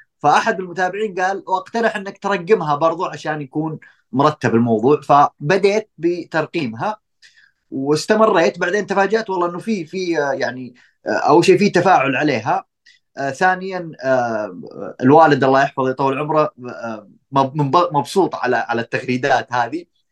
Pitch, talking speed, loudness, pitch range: 165 Hz, 110 wpm, -17 LUFS, 140-190 Hz